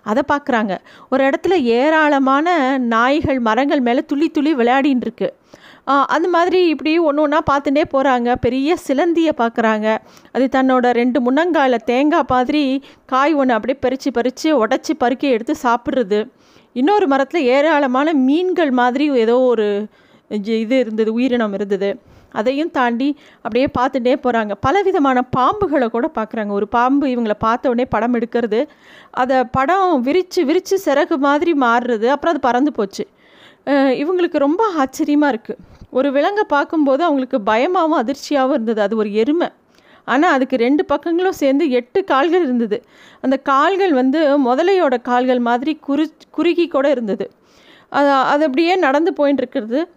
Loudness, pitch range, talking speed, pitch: -16 LUFS, 245-305 Hz, 135 wpm, 275 Hz